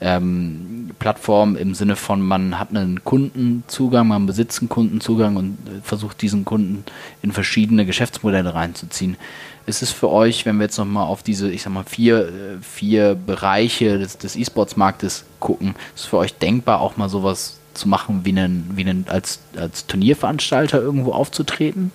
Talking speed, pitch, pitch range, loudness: 160 wpm, 100 Hz, 95-115 Hz, -19 LUFS